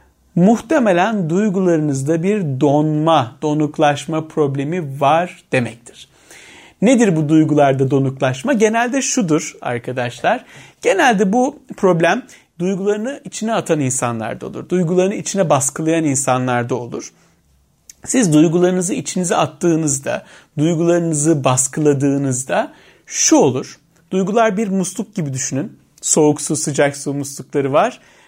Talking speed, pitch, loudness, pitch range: 100 wpm, 160 Hz, -17 LUFS, 140-190 Hz